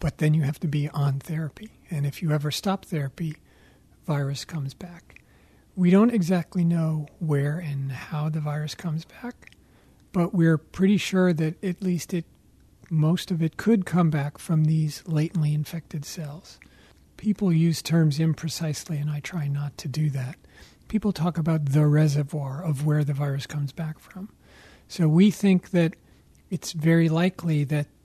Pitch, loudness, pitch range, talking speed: 160 Hz, -25 LUFS, 150-175 Hz, 165 wpm